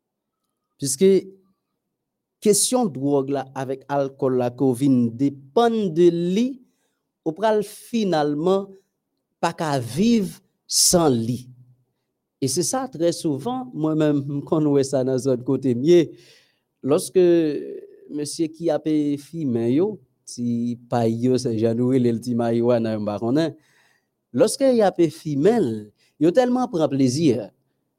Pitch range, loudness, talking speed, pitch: 130-190 Hz, -21 LUFS, 110 wpm, 150 Hz